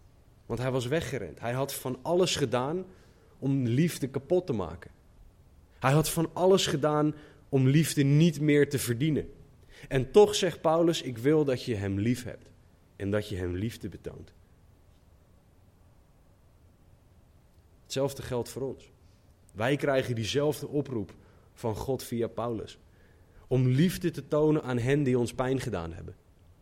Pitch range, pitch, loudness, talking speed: 95-145 Hz, 125 Hz, -28 LUFS, 145 wpm